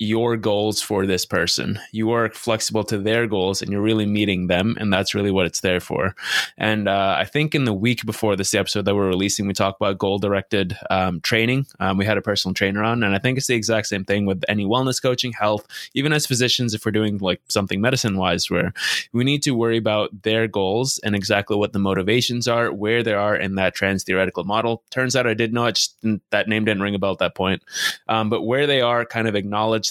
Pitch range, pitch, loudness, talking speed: 100-115 Hz, 105 Hz, -20 LUFS, 235 wpm